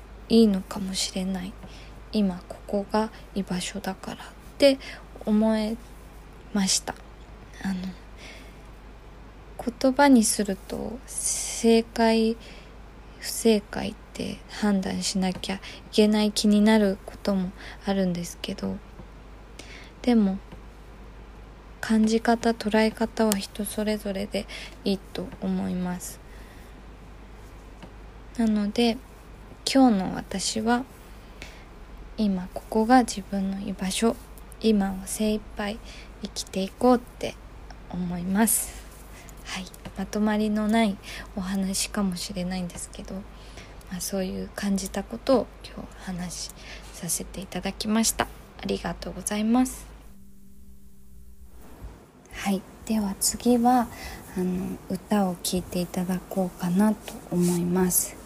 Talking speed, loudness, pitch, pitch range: 215 characters per minute, -26 LUFS, 200 Hz, 185-220 Hz